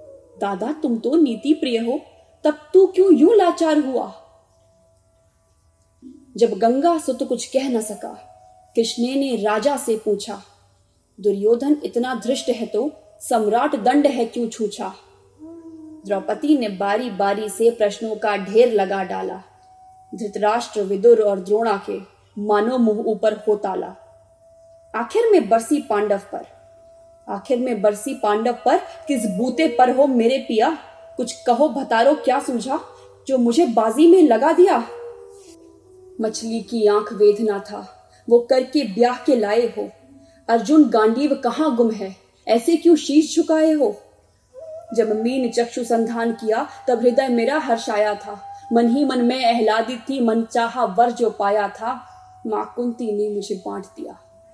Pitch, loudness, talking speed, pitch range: 240 Hz, -19 LUFS, 140 wpm, 215-295 Hz